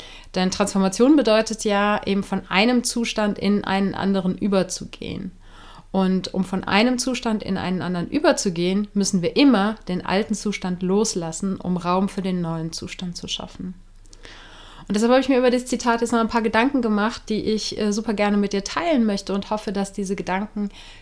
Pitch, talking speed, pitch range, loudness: 200 Hz, 180 wpm, 190-220 Hz, -22 LUFS